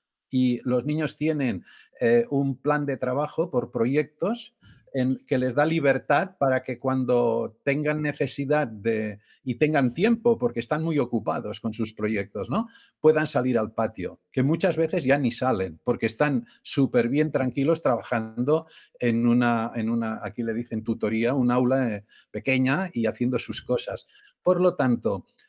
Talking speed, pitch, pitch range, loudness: 160 wpm, 130 Hz, 120-150 Hz, -25 LUFS